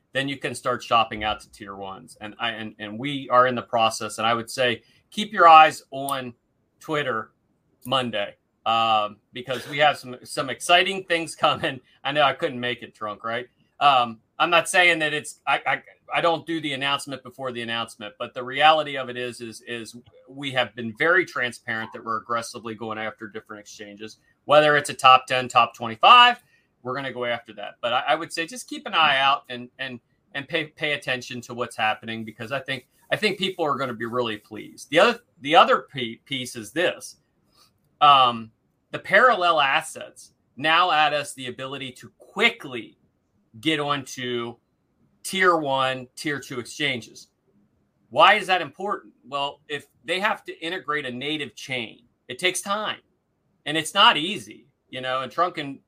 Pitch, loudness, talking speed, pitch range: 130 Hz, -22 LUFS, 185 wpm, 115-150 Hz